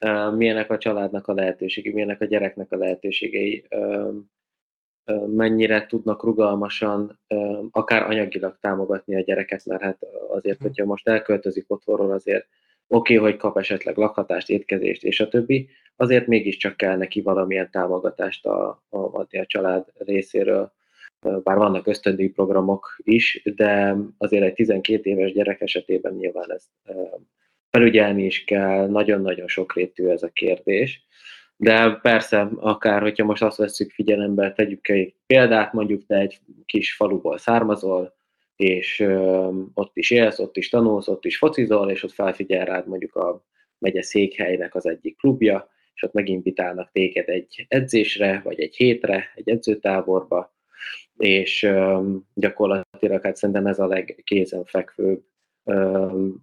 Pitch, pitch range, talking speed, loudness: 100 Hz, 95-110 Hz, 130 wpm, -21 LUFS